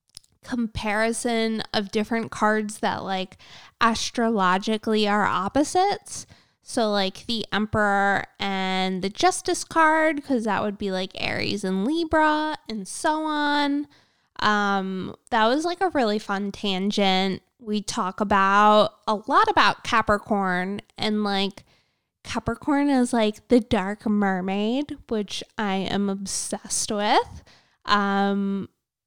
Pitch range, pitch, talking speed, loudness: 200-250 Hz, 215 Hz, 120 wpm, -23 LUFS